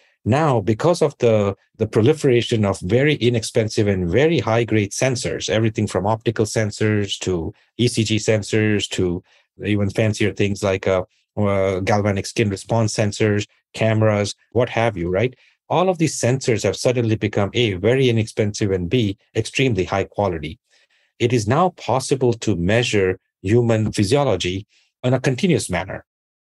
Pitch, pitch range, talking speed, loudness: 110 Hz, 100-120 Hz, 145 wpm, -20 LUFS